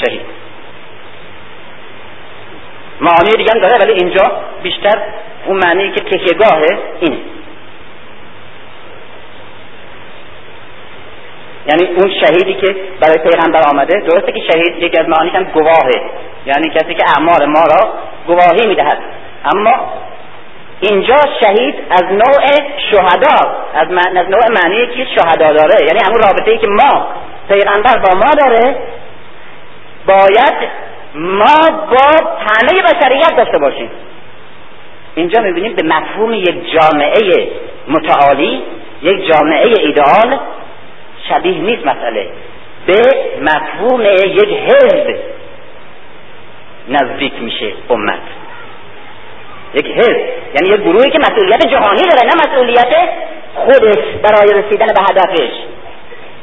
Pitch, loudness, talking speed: 260 Hz, -10 LUFS, 105 wpm